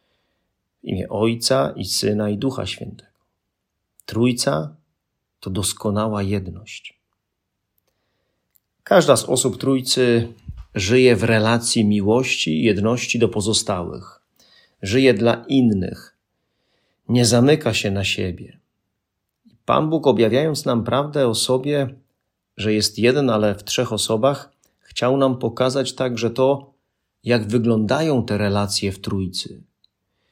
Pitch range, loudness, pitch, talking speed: 100-125 Hz, -19 LUFS, 110 Hz, 110 wpm